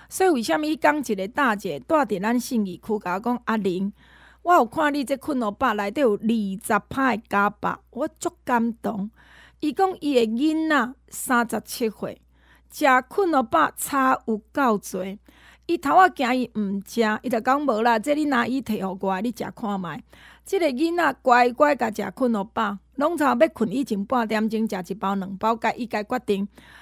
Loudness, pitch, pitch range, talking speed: -23 LUFS, 240 Hz, 210-285 Hz, 255 characters per minute